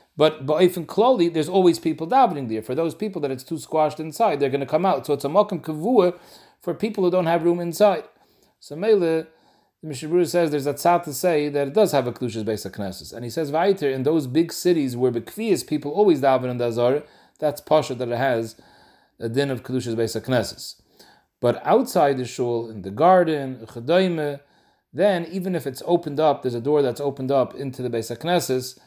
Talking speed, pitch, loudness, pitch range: 205 wpm, 150 Hz, -22 LUFS, 130-175 Hz